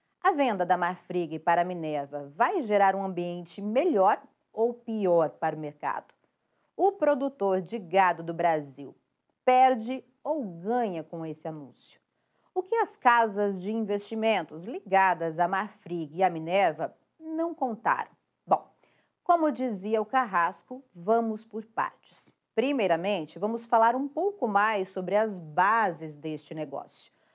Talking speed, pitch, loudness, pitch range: 135 wpm, 200 Hz, -28 LUFS, 170-240 Hz